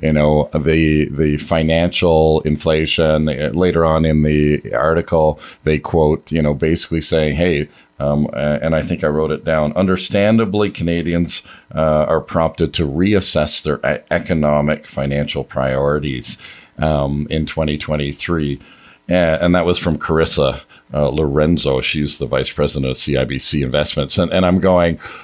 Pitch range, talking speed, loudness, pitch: 75-85 Hz, 140 wpm, -16 LUFS, 75 Hz